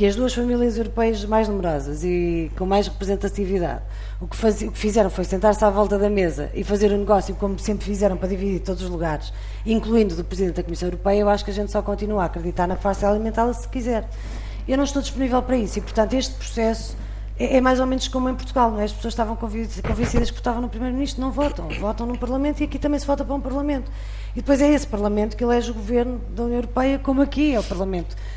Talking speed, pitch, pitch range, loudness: 240 wpm, 215 Hz, 195-245 Hz, -22 LUFS